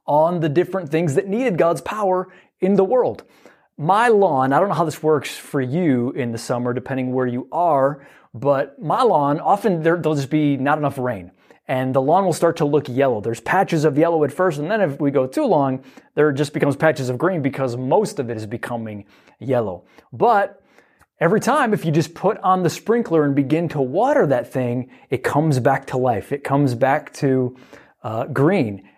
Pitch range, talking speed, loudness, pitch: 130-170 Hz, 205 wpm, -19 LUFS, 145 Hz